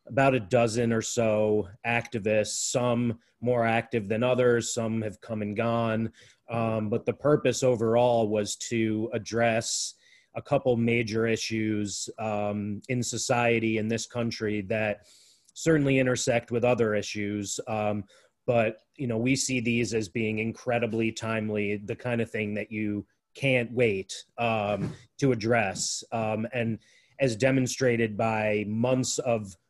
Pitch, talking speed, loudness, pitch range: 115 Hz, 140 wpm, -27 LUFS, 110-120 Hz